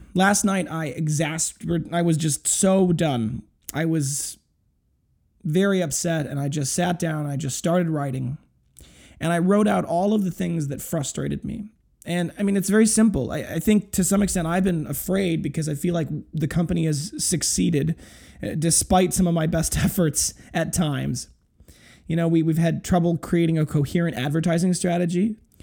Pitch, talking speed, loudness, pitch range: 165 Hz, 180 wpm, -23 LUFS, 155-180 Hz